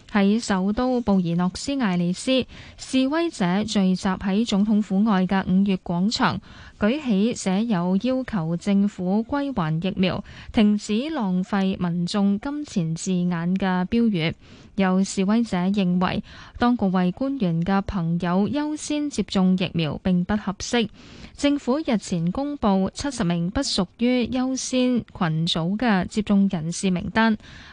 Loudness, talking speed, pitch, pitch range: -23 LUFS, 210 characters per minute, 200 Hz, 185-235 Hz